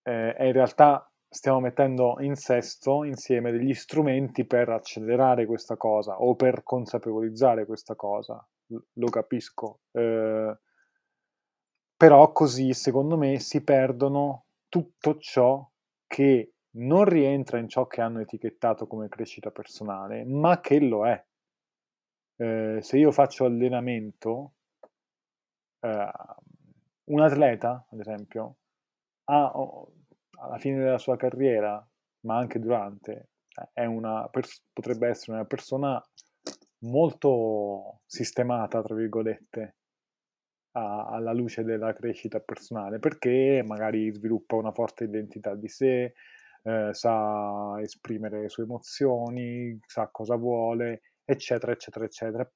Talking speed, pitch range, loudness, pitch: 115 wpm, 110-135 Hz, -26 LUFS, 120 Hz